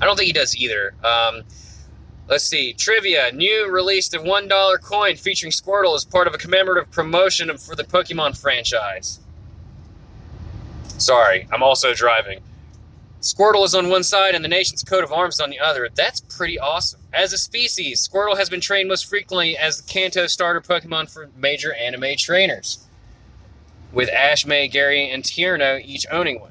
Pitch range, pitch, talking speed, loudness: 125-185 Hz, 160 Hz, 170 wpm, -17 LUFS